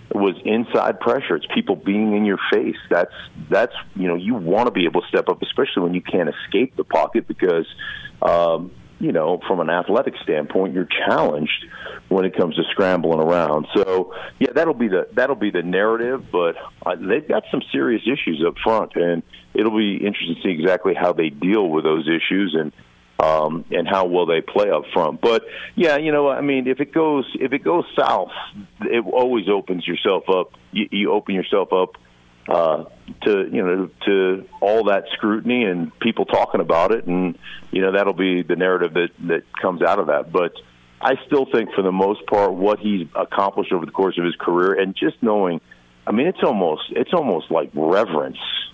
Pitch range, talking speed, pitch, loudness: 85-115 Hz, 200 wpm, 95 Hz, -20 LUFS